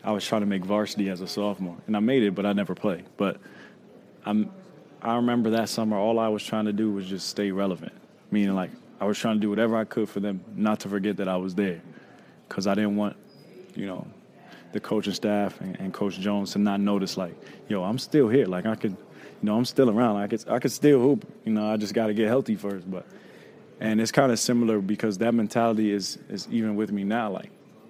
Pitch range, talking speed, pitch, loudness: 100-115 Hz, 240 wpm, 105 Hz, -26 LUFS